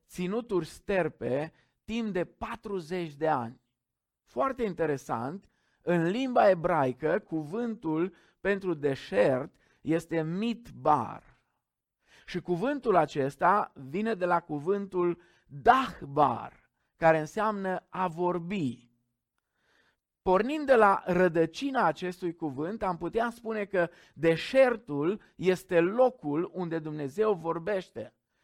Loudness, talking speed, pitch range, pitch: -29 LUFS, 95 wpm, 155-200 Hz, 175 Hz